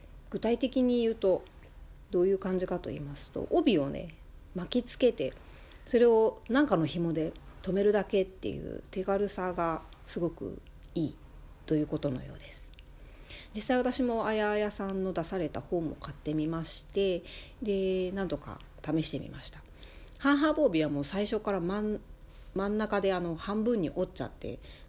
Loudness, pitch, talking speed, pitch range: -31 LUFS, 185 Hz, 300 characters per minute, 145-210 Hz